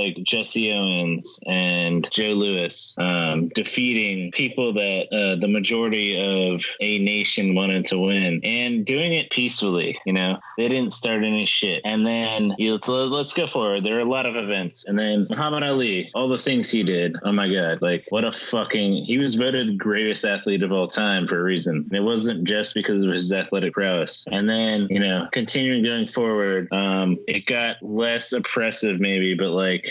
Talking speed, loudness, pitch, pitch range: 185 wpm, -22 LUFS, 100 Hz, 95-115 Hz